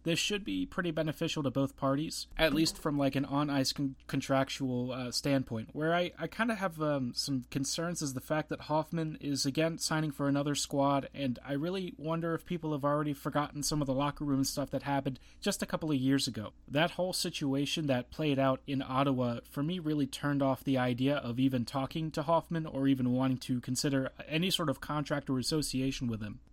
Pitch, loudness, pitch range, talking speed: 145 Hz, -33 LUFS, 135-160 Hz, 215 wpm